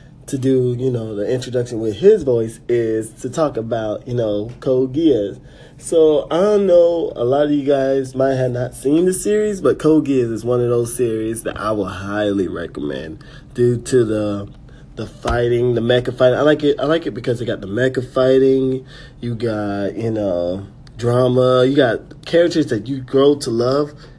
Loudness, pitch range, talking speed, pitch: -17 LUFS, 115-140 Hz, 190 wpm, 125 Hz